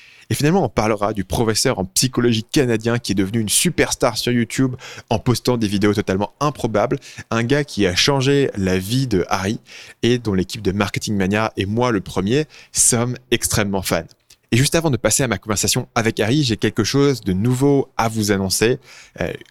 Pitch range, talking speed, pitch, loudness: 105-130 Hz, 195 wpm, 115 Hz, -19 LUFS